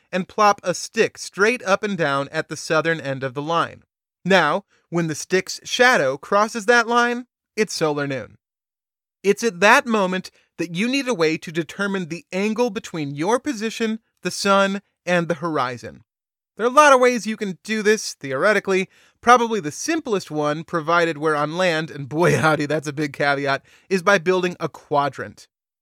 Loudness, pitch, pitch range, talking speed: -20 LUFS, 185 Hz, 155-215 Hz, 180 wpm